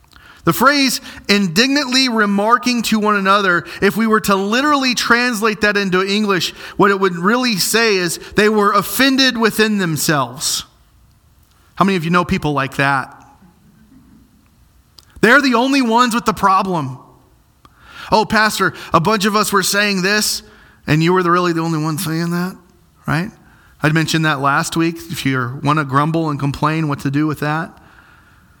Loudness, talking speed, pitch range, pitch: -15 LUFS, 165 wpm, 160-220 Hz, 195 Hz